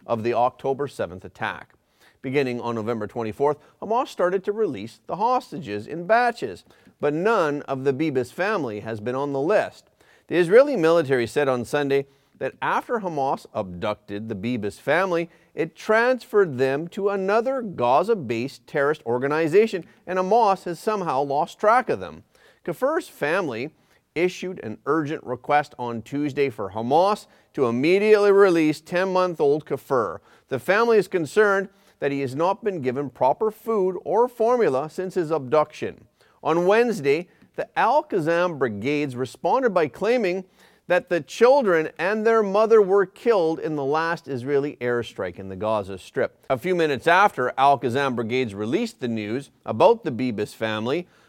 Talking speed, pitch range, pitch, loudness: 155 wpm, 130-200 Hz, 155 Hz, -23 LUFS